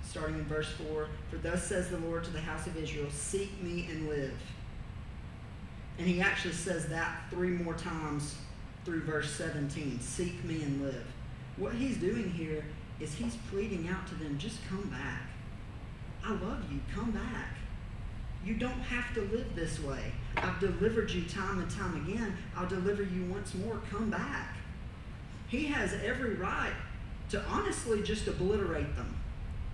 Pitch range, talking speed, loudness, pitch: 140-190 Hz, 165 wpm, -36 LUFS, 165 Hz